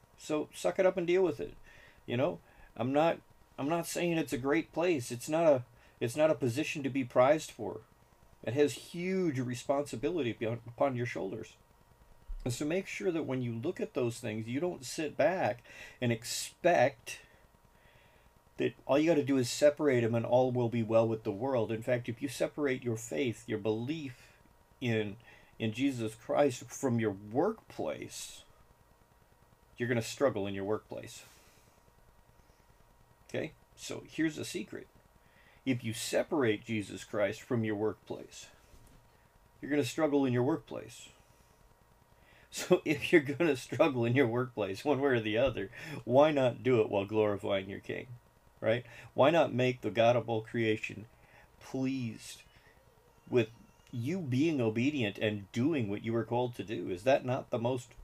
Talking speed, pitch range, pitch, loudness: 170 wpm, 110-140 Hz, 120 Hz, -32 LUFS